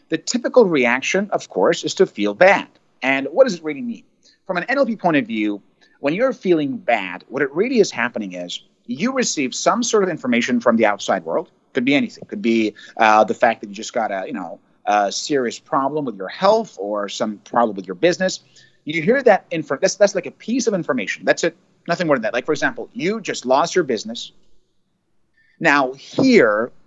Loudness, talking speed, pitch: -19 LUFS, 210 wpm, 170 Hz